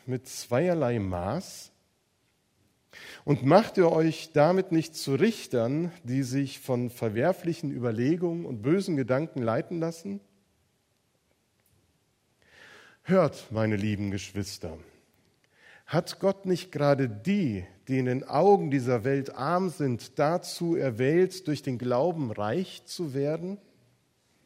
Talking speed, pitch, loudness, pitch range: 115 wpm, 145 Hz, -28 LUFS, 125-175 Hz